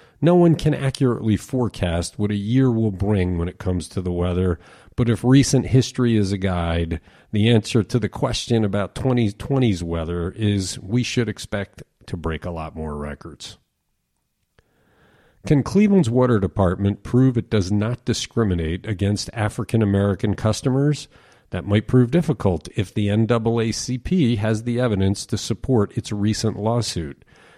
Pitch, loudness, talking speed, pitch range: 110 Hz, -21 LUFS, 150 wpm, 95-125 Hz